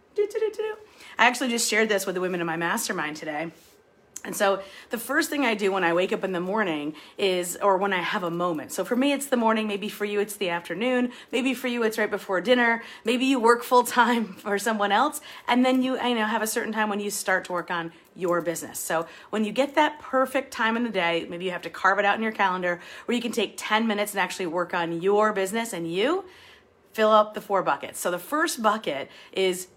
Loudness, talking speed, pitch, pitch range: -25 LUFS, 245 wpm, 210 Hz, 185-240 Hz